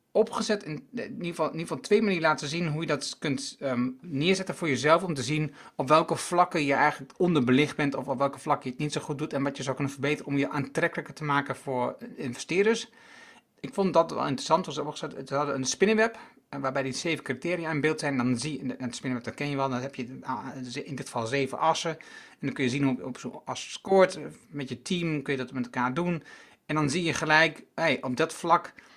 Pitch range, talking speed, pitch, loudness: 135-165 Hz, 240 wpm, 150 Hz, -28 LUFS